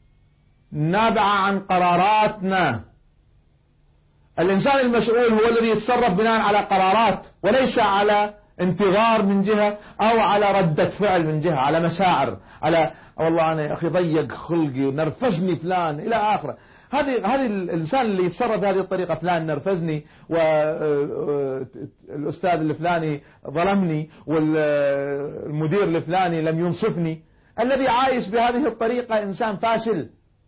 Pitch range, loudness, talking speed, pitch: 160-215 Hz, -21 LUFS, 110 wpm, 185 Hz